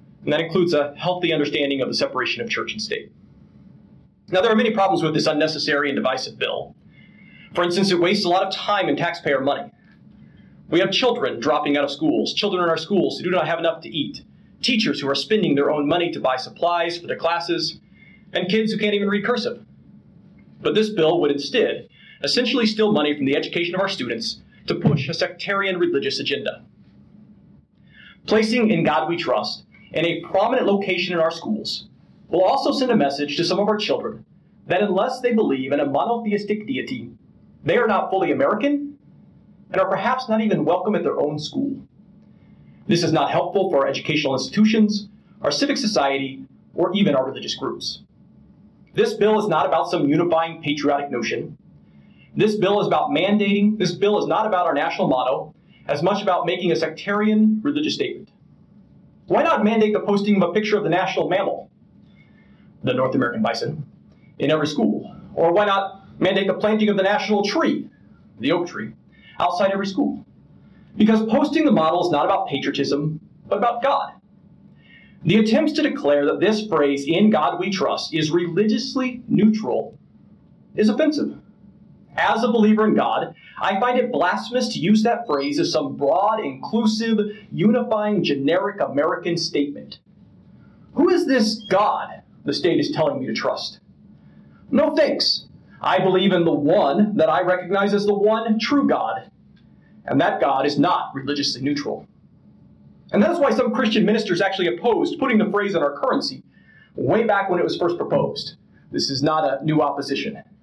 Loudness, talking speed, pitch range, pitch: -21 LUFS, 180 wpm, 165-220 Hz, 195 Hz